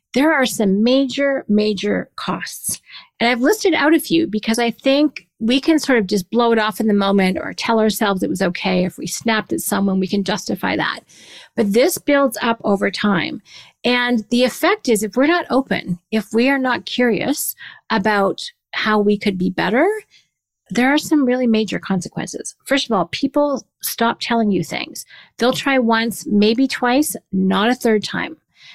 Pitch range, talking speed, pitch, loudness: 205-265 Hz, 185 wpm, 230 Hz, -18 LUFS